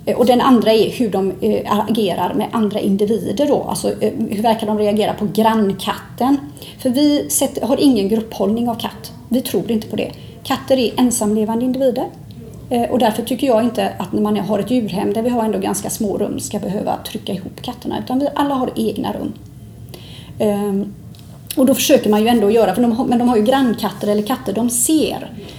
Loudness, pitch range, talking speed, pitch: -17 LUFS, 210-255 Hz, 190 wpm, 225 Hz